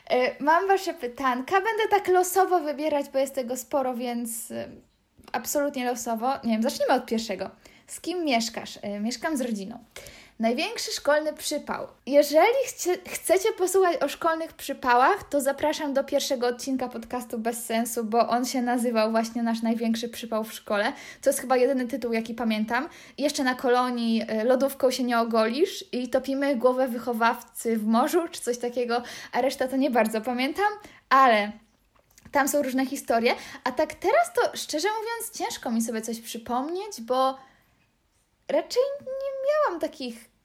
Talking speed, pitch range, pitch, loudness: 150 wpm, 235-295 Hz, 260 Hz, -26 LUFS